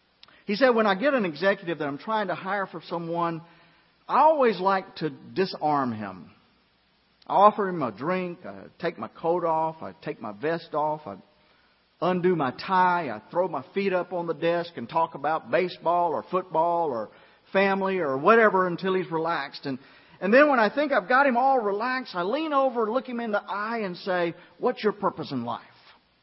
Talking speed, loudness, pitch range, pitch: 195 wpm, -25 LUFS, 165-205 Hz, 180 Hz